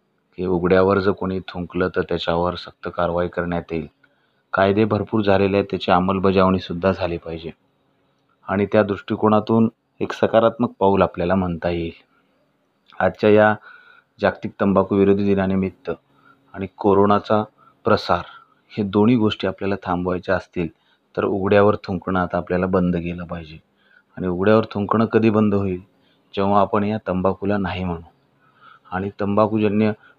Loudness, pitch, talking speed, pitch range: -20 LUFS, 95 Hz, 130 wpm, 90-105 Hz